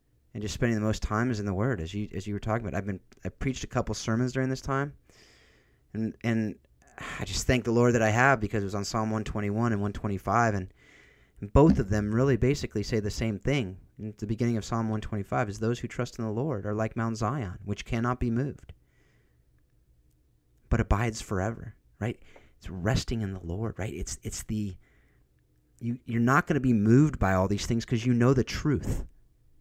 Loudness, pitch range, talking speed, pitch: -29 LUFS, 100-120 Hz, 230 wpm, 110 Hz